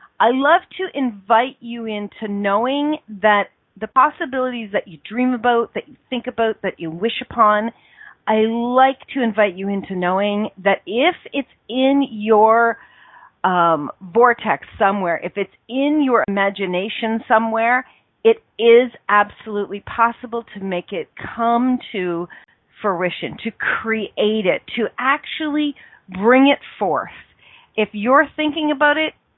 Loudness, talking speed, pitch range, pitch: -18 LUFS, 135 wpm, 205-255 Hz, 230 Hz